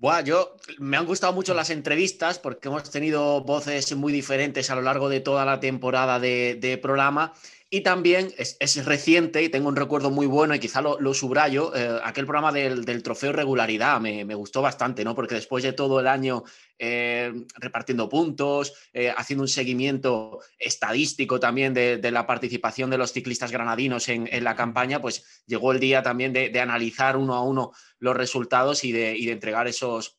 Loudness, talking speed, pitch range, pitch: -24 LUFS, 195 wpm, 120-145 Hz, 130 Hz